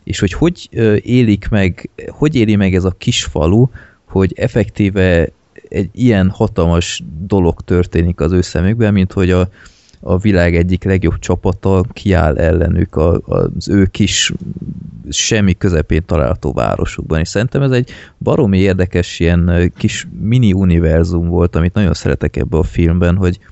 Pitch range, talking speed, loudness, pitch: 85-105 Hz, 145 wpm, -14 LUFS, 95 Hz